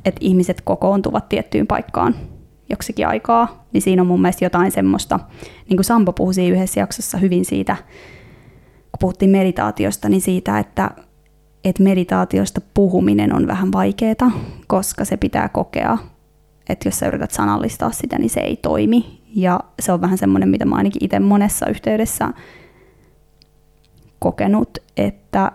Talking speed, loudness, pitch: 145 wpm, -18 LUFS, 180 Hz